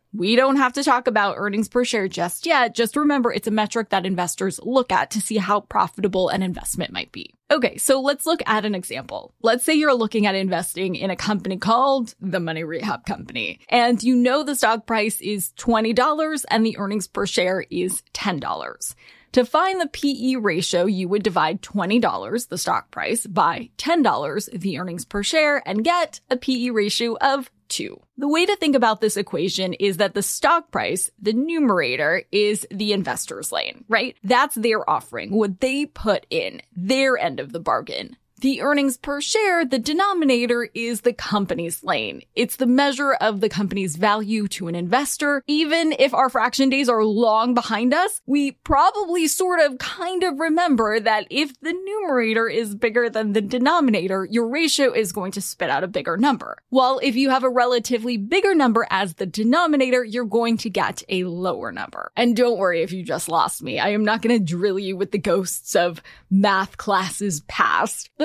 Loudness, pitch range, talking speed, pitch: -21 LUFS, 205-270 Hz, 190 wpm, 230 Hz